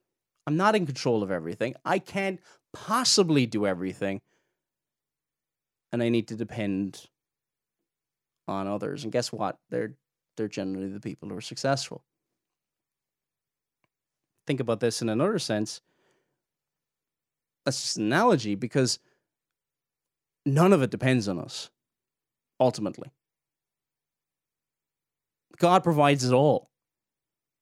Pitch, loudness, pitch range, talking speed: 125 Hz, -27 LUFS, 105-155 Hz, 110 wpm